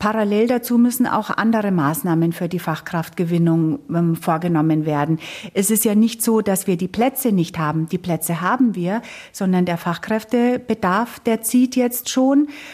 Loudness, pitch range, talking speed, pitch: -19 LUFS, 170-230 Hz, 160 wpm, 195 Hz